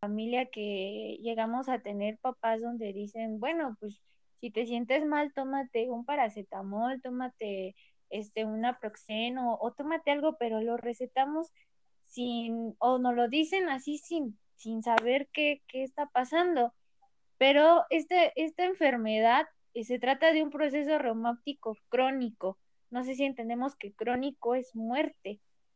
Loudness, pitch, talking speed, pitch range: -31 LUFS, 245 Hz, 135 wpm, 225-285 Hz